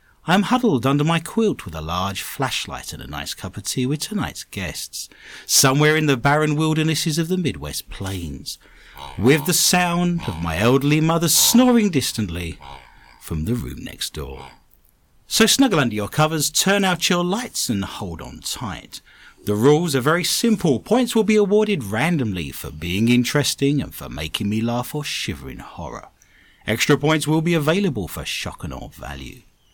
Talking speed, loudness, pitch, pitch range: 175 wpm, -20 LUFS, 145 Hz, 105-175 Hz